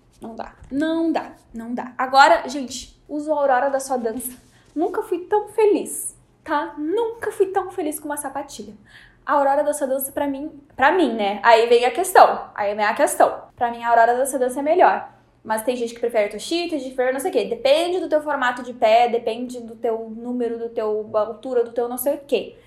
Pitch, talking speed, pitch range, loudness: 270 Hz, 220 wpm, 235-315 Hz, -20 LUFS